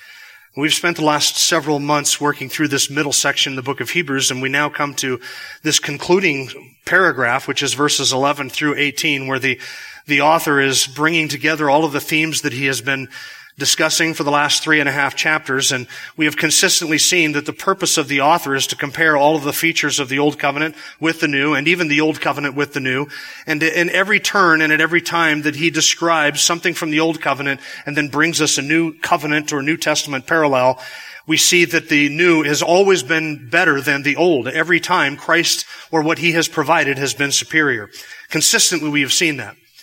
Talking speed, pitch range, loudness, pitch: 215 wpm, 140-165 Hz, -16 LUFS, 150 Hz